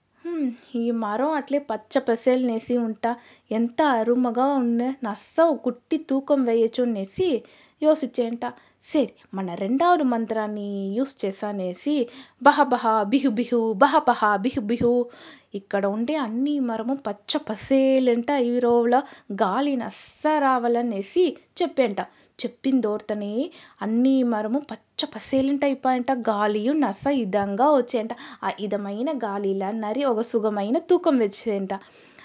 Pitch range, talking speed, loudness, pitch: 220-275 Hz, 110 wpm, -23 LUFS, 245 Hz